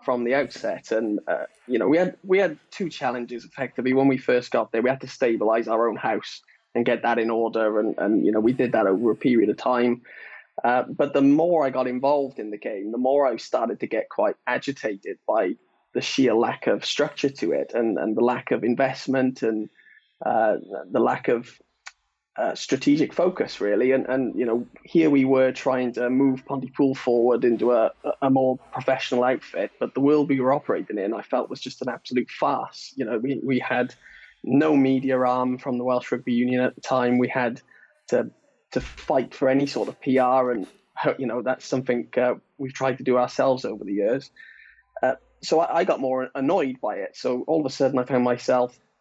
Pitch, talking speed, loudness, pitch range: 130 Hz, 210 wpm, -23 LUFS, 125-135 Hz